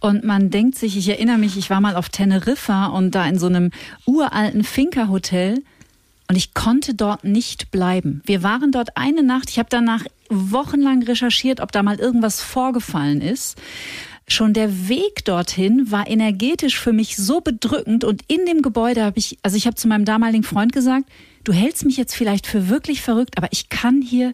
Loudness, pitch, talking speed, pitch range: -18 LUFS, 225 Hz, 190 wpm, 200-255 Hz